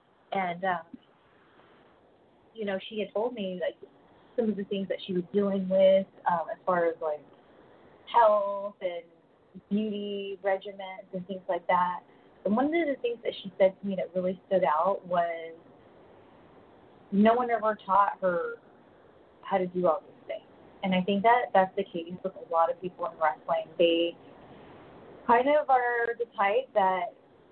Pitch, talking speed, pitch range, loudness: 195 Hz, 170 wpm, 180-215 Hz, -28 LUFS